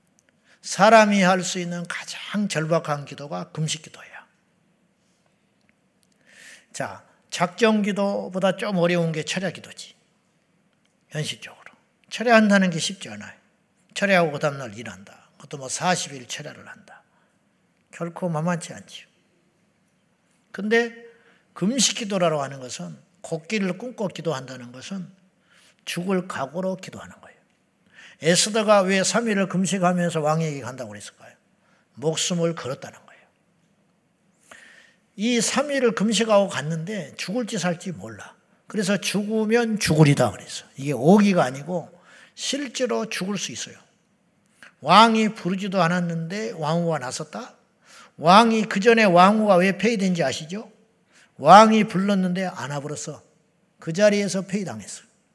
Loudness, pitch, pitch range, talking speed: -21 LUFS, 185 Hz, 165-210 Hz, 270 characters per minute